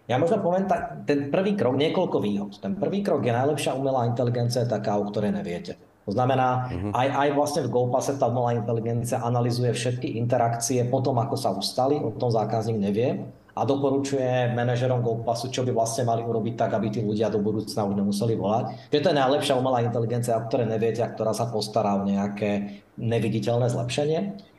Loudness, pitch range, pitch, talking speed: -25 LUFS, 115-135 Hz, 120 Hz, 190 wpm